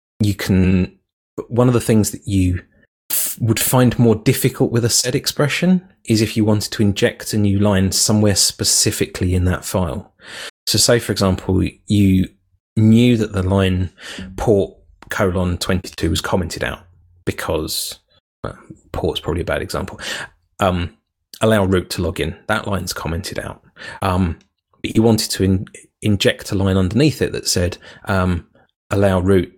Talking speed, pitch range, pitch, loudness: 160 wpm, 95-115 Hz, 100 Hz, -18 LUFS